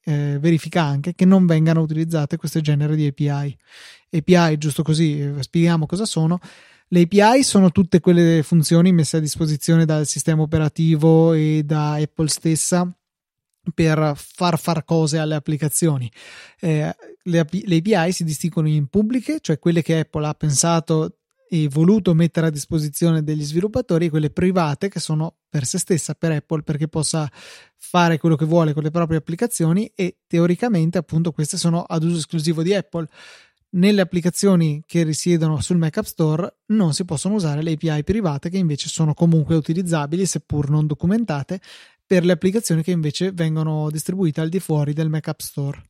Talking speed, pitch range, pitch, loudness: 165 wpm, 155-180 Hz, 165 Hz, -19 LUFS